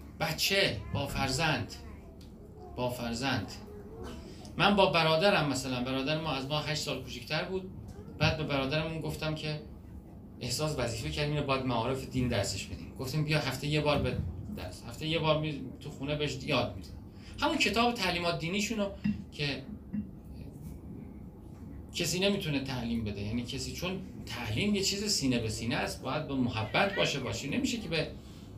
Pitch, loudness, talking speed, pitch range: 140 Hz, -32 LUFS, 155 wpm, 120-155 Hz